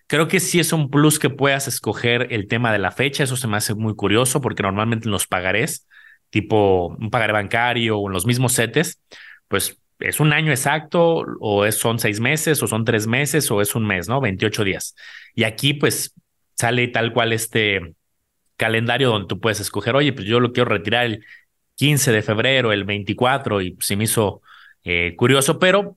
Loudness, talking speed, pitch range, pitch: -19 LUFS, 195 wpm, 105-140 Hz, 115 Hz